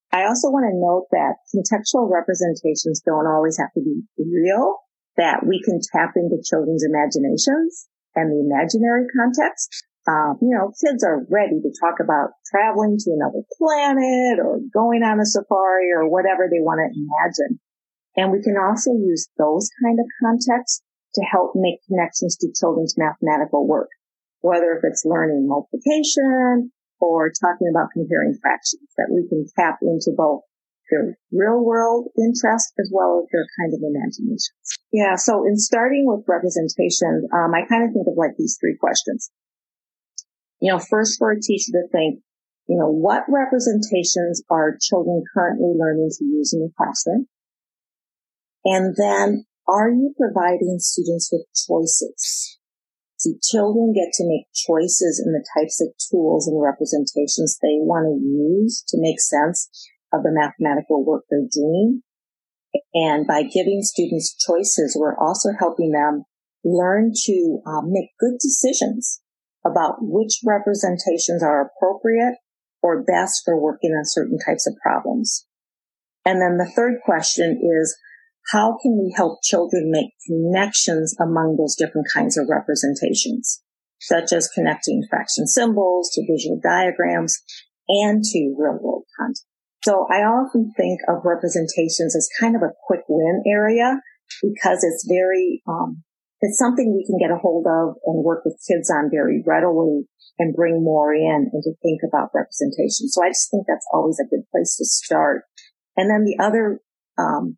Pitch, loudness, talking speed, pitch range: 185 Hz, -19 LUFS, 155 wpm, 165-230 Hz